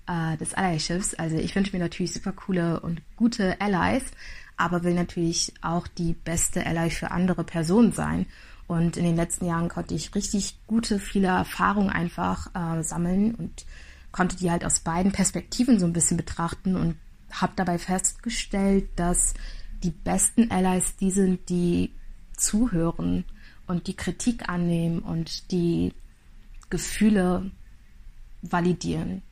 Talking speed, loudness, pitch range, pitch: 140 wpm, -26 LUFS, 165-195 Hz, 175 Hz